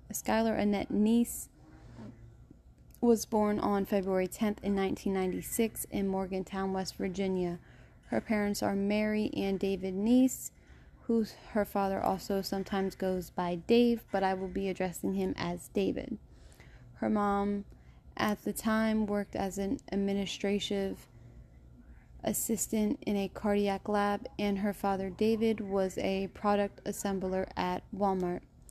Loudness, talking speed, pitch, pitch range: -32 LUFS, 125 wpm, 200 Hz, 190-210 Hz